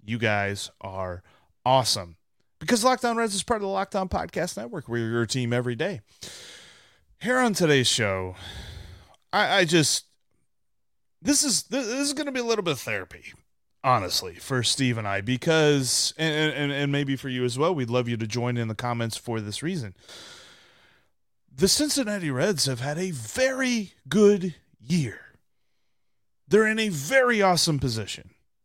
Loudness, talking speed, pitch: -25 LUFS, 160 wpm, 135 Hz